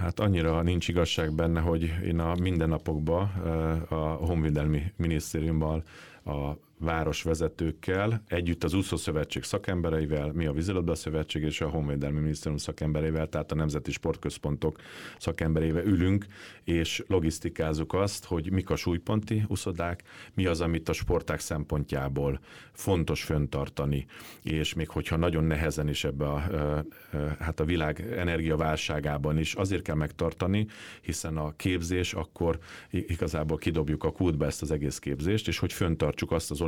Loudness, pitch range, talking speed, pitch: -30 LUFS, 75-90 Hz, 140 wpm, 80 Hz